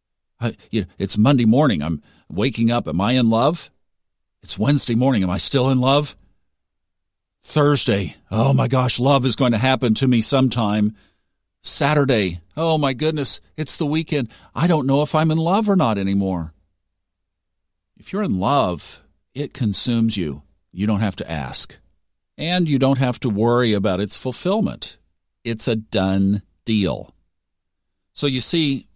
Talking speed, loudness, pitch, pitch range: 160 wpm, -20 LUFS, 110 Hz, 90-135 Hz